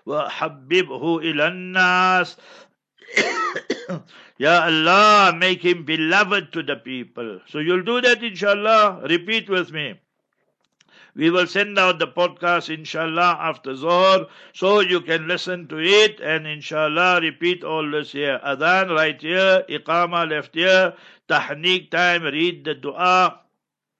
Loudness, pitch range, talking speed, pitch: -19 LUFS, 160-185 Hz, 130 wpm, 175 Hz